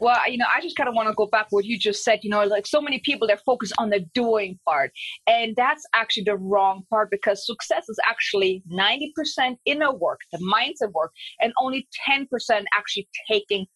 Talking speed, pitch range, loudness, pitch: 210 wpm, 205-265 Hz, -23 LUFS, 220 Hz